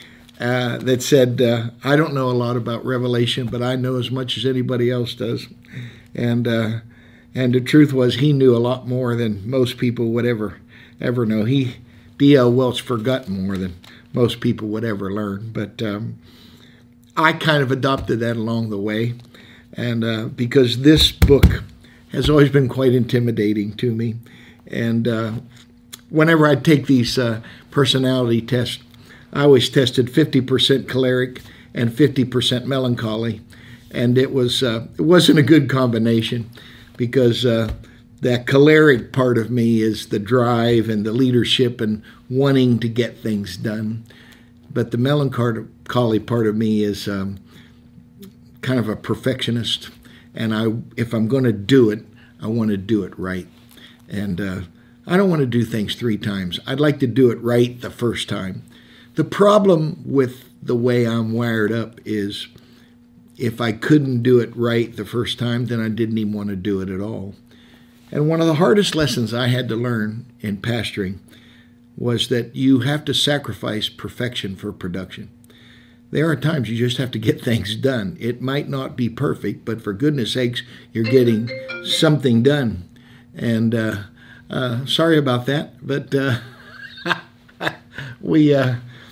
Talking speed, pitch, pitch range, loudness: 165 wpm, 120 Hz, 115-130 Hz, -19 LUFS